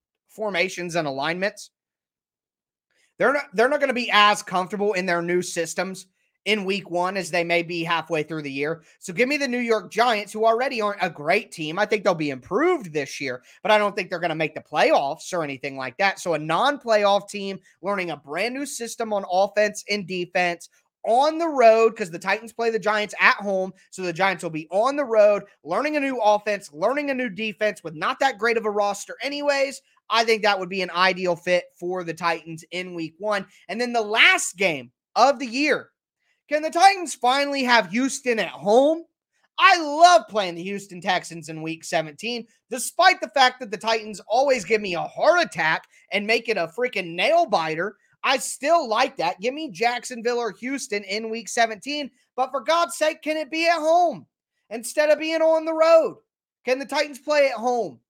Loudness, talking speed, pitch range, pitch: -22 LUFS, 205 wpm, 180-265 Hz, 215 Hz